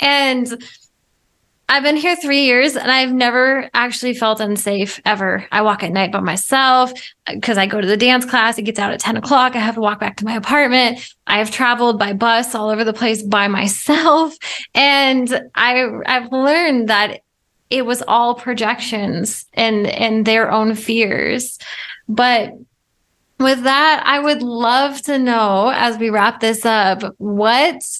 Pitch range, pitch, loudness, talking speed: 215-260 Hz, 235 Hz, -15 LUFS, 165 wpm